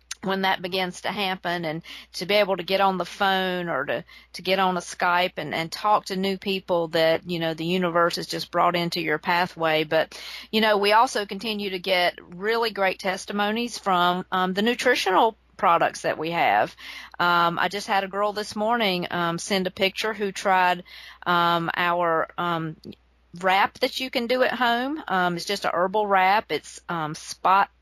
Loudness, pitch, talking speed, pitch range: -23 LUFS, 185 Hz, 195 wpm, 175-205 Hz